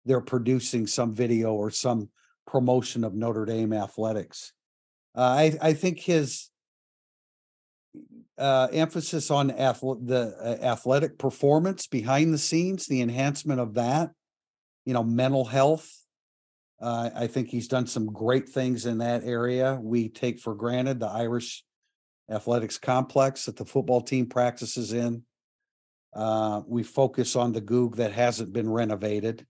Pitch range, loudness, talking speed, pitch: 115-135 Hz, -26 LUFS, 140 wpm, 125 Hz